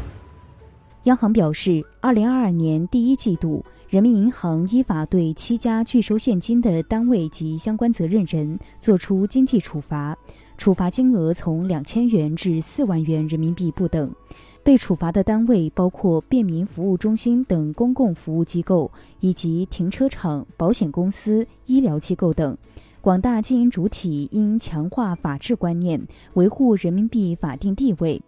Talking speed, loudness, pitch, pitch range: 245 characters per minute, -20 LUFS, 185 Hz, 165-230 Hz